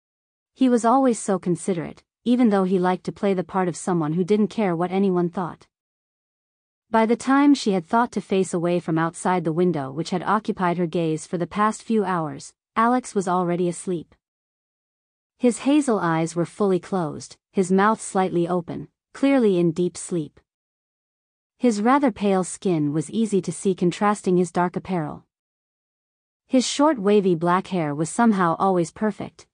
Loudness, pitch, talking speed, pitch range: -22 LUFS, 185 Hz, 170 wpm, 175-215 Hz